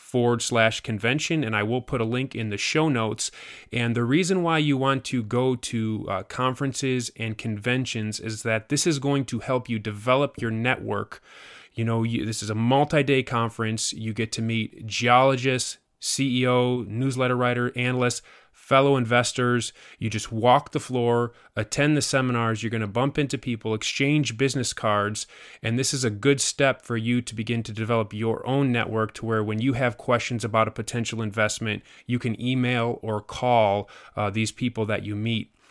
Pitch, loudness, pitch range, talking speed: 120 Hz, -25 LUFS, 110-130 Hz, 180 wpm